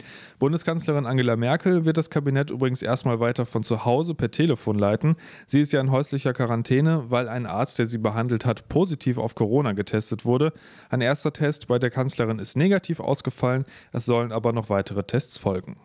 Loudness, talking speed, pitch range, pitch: -24 LUFS, 185 wpm, 115-145 Hz, 125 Hz